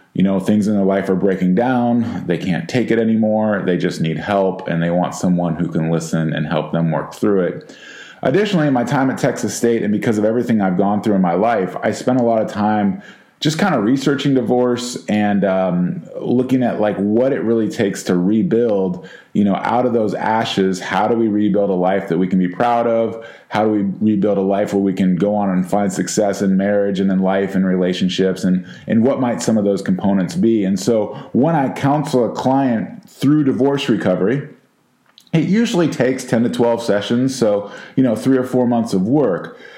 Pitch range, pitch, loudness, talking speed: 95-120 Hz, 105 Hz, -17 LUFS, 215 wpm